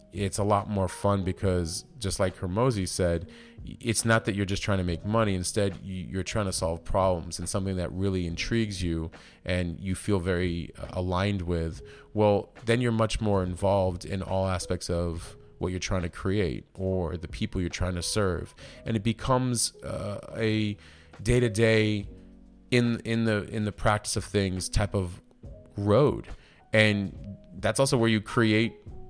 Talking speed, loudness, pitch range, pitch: 175 wpm, -28 LUFS, 90-110 Hz, 100 Hz